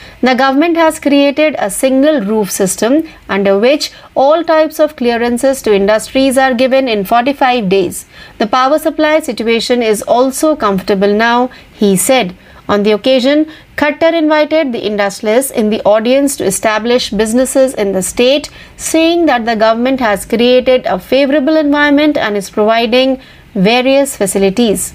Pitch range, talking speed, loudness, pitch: 215-290 Hz, 150 wpm, -11 LUFS, 255 Hz